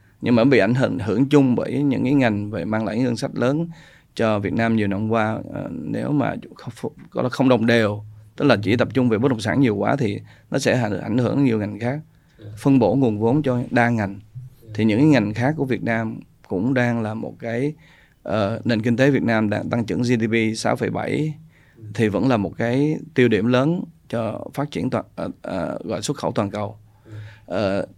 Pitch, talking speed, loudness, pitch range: 120 Hz, 210 wpm, -21 LUFS, 110-135 Hz